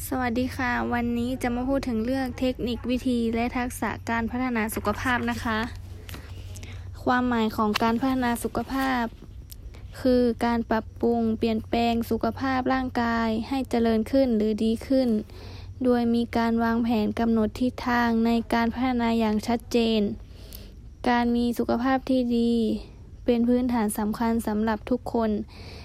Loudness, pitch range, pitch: -25 LUFS, 220-245 Hz, 235 Hz